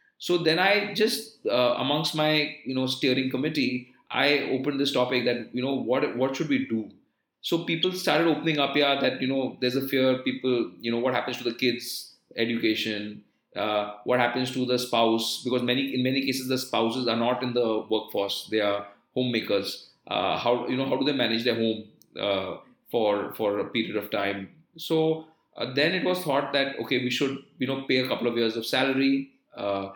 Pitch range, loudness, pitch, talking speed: 115-140 Hz, -26 LUFS, 130 Hz, 205 wpm